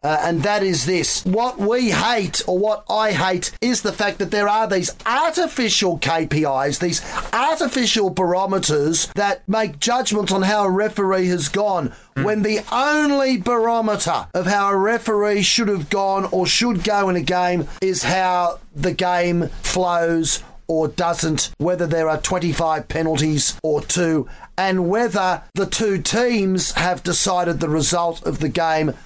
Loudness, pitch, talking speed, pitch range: -19 LUFS, 185 Hz, 155 wpm, 170-210 Hz